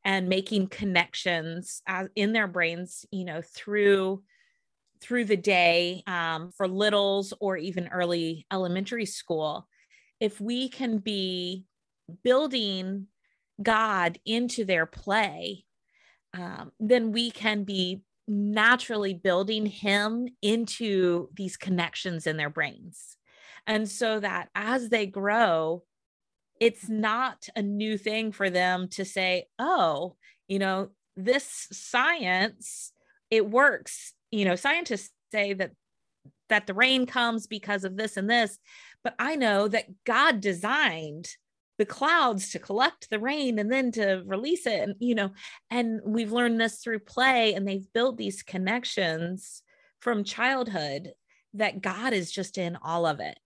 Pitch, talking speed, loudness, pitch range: 205 Hz, 135 wpm, -27 LUFS, 185-230 Hz